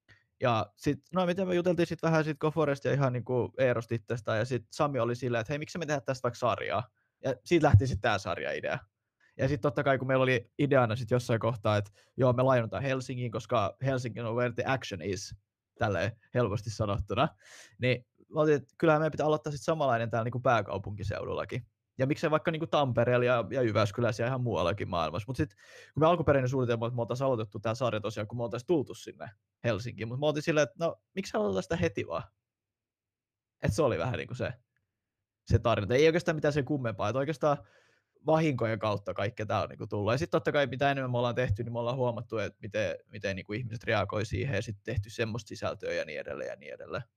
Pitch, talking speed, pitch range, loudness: 125 Hz, 215 wpm, 110-145 Hz, -30 LUFS